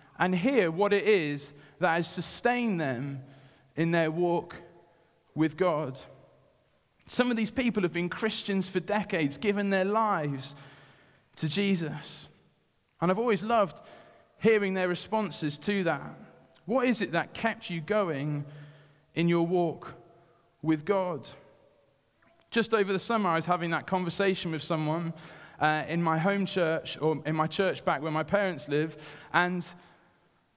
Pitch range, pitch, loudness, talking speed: 155-195 Hz, 170 Hz, -29 LUFS, 145 wpm